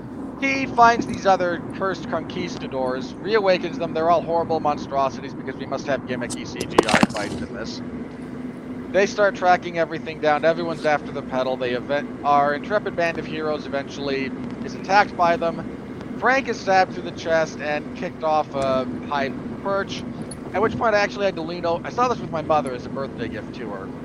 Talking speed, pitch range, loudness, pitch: 185 wpm, 145-205 Hz, -23 LUFS, 170 Hz